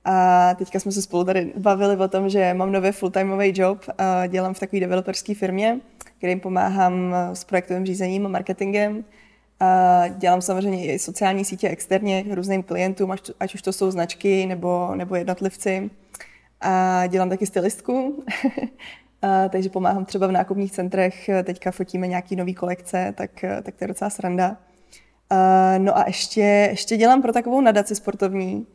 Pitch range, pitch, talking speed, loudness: 185-200 Hz, 190 Hz, 155 wpm, -21 LUFS